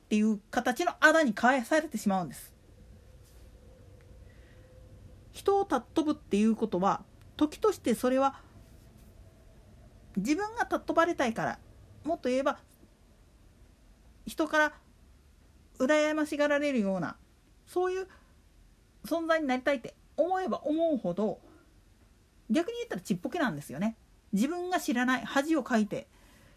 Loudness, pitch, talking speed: -30 LUFS, 255 Hz, 265 characters per minute